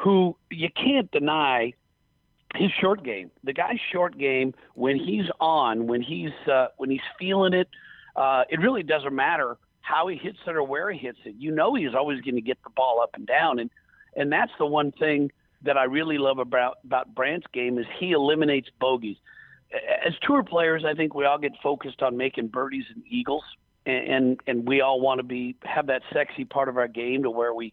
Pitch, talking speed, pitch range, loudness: 140 Hz, 210 wpm, 130-170 Hz, -25 LUFS